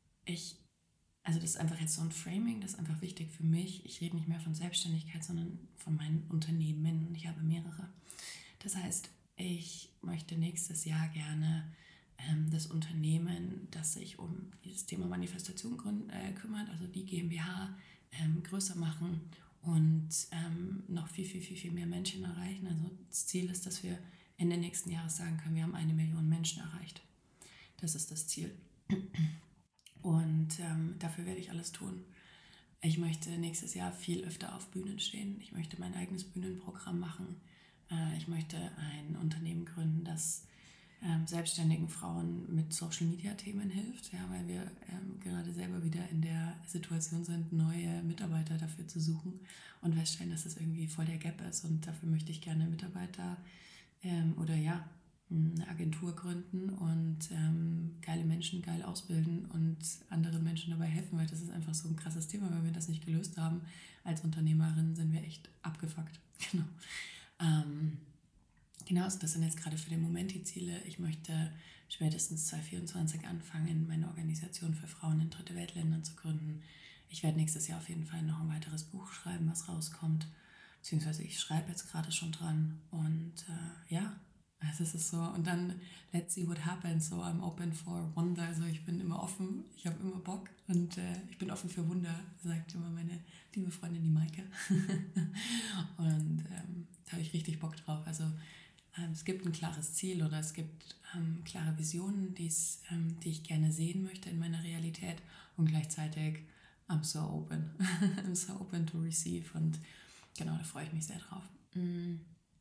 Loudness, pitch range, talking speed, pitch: -38 LUFS, 160-180 Hz, 175 wpm, 165 Hz